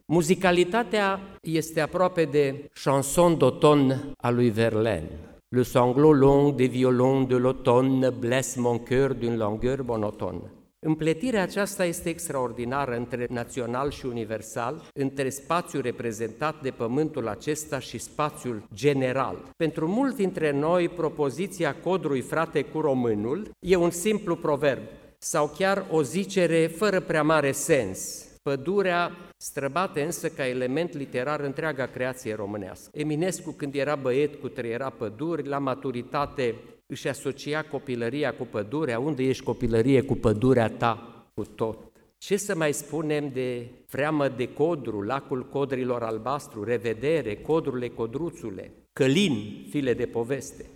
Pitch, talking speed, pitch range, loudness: 140 Hz, 130 wpm, 120-155 Hz, -26 LUFS